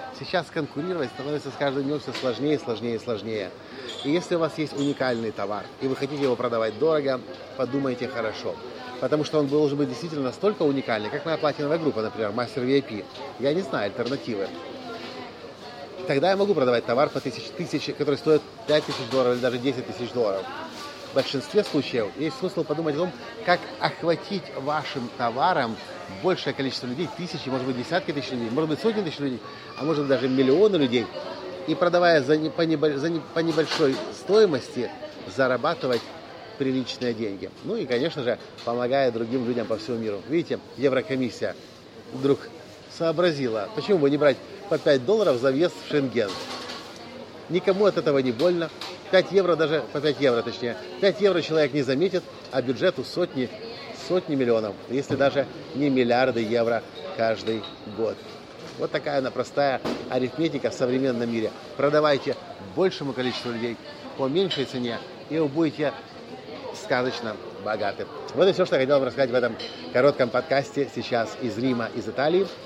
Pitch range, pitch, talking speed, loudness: 125-160 Hz, 140 Hz, 160 wpm, -25 LUFS